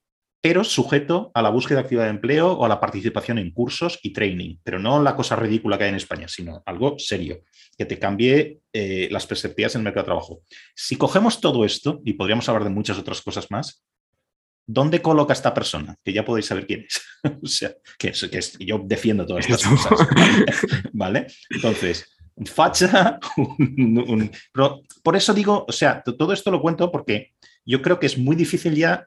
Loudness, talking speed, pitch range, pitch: -21 LUFS, 200 wpm, 110-155 Hz, 130 Hz